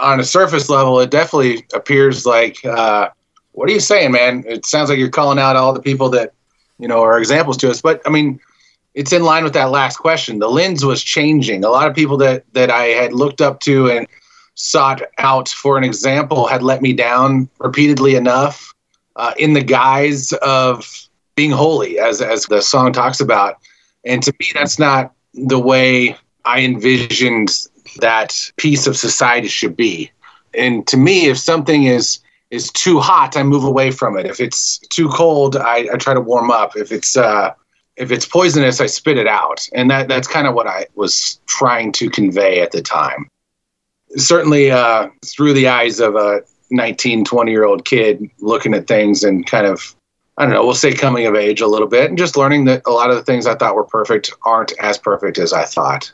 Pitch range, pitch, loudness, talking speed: 125-145 Hz, 130 Hz, -13 LUFS, 205 wpm